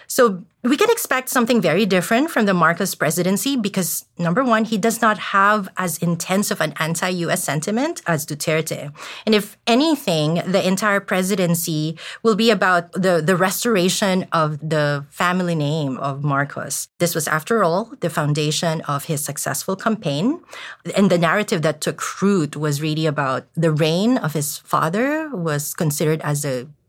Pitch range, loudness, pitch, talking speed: 155-210 Hz, -19 LUFS, 175 Hz, 165 wpm